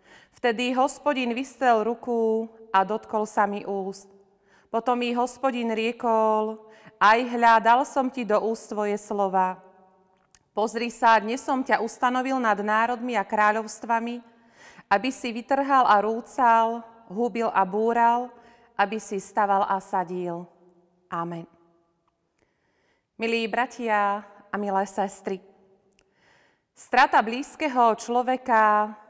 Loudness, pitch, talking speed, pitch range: -24 LUFS, 220 Hz, 105 wpm, 200-235 Hz